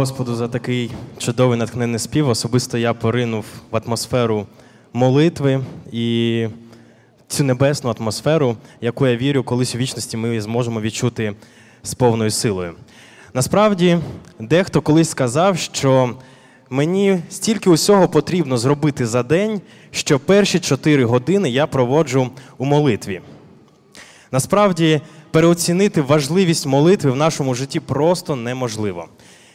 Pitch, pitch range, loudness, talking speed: 130 Hz, 120-155 Hz, -18 LUFS, 115 wpm